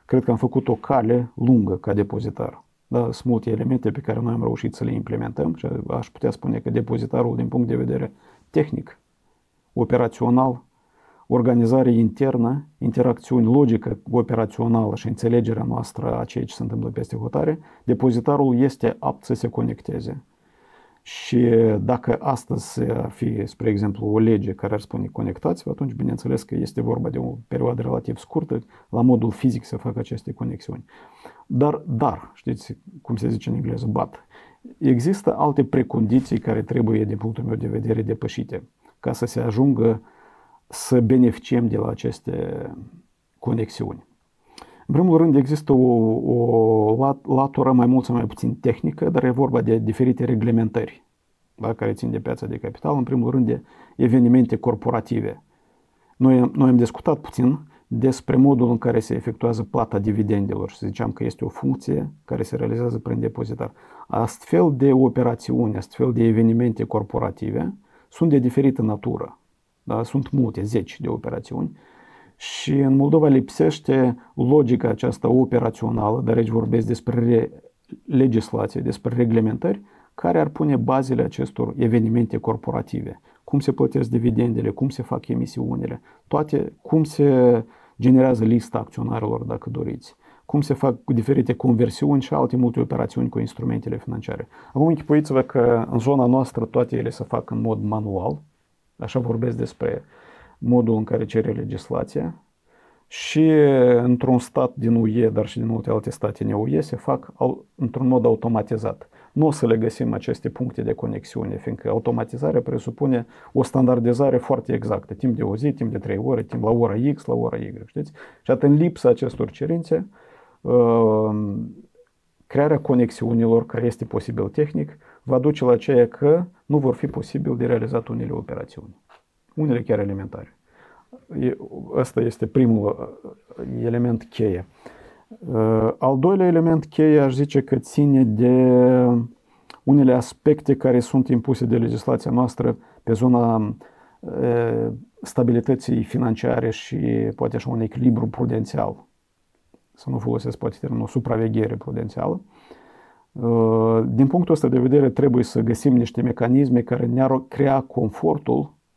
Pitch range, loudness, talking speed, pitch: 115-130 Hz, -21 LUFS, 145 wpm, 120 Hz